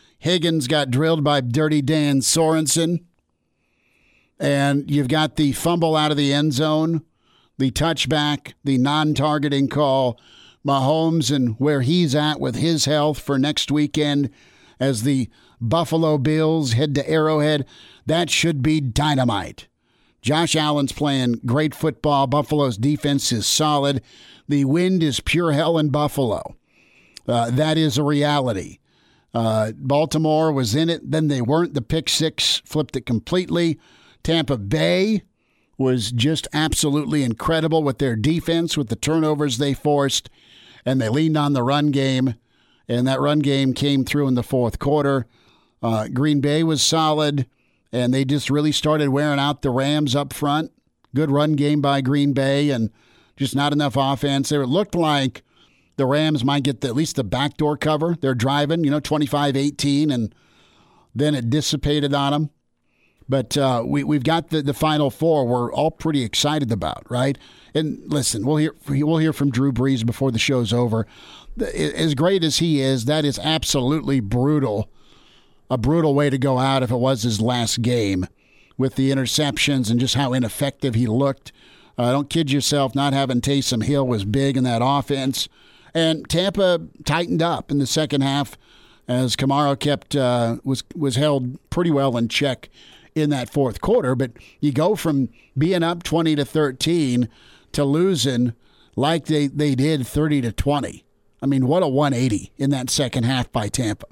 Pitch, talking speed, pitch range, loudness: 145 Hz, 165 wpm, 130-155 Hz, -20 LUFS